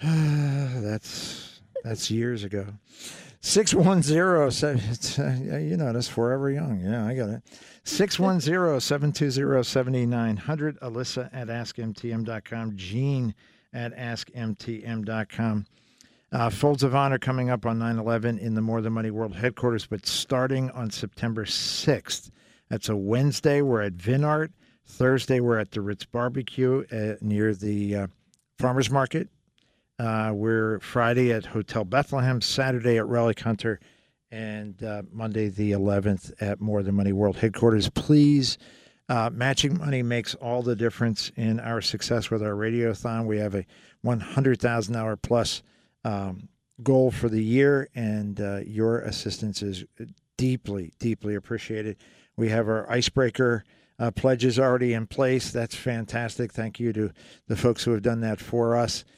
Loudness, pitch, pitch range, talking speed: -26 LUFS, 115 Hz, 110-130 Hz, 135 wpm